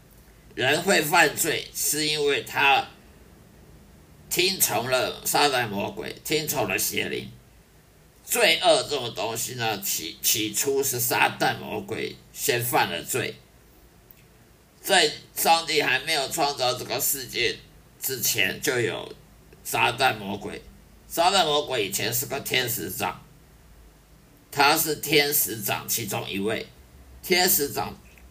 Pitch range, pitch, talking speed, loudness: 105-155 Hz, 140 Hz, 175 characters per minute, -23 LUFS